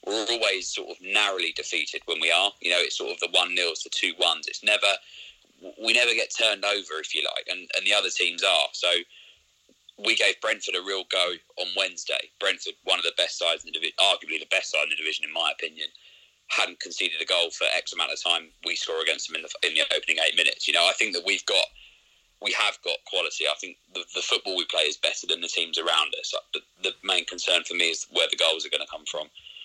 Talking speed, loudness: 250 wpm, -24 LUFS